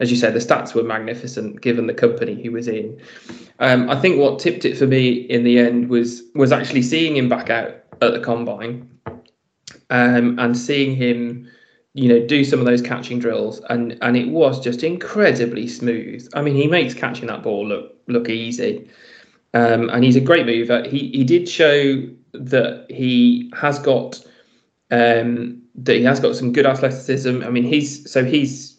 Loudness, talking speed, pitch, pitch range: -18 LUFS, 190 wpm, 125 Hz, 120-140 Hz